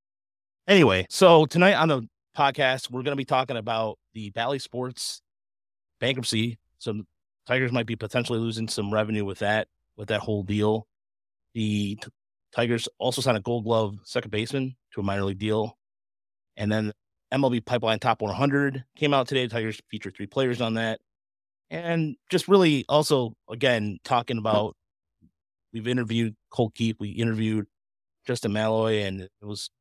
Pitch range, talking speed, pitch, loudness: 105-125 Hz, 155 wpm, 110 Hz, -25 LUFS